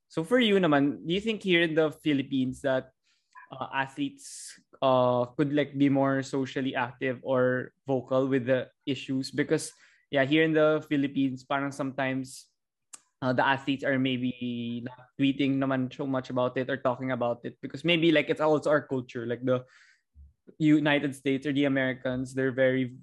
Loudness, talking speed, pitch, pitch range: -28 LUFS, 170 wpm, 135 Hz, 130-145 Hz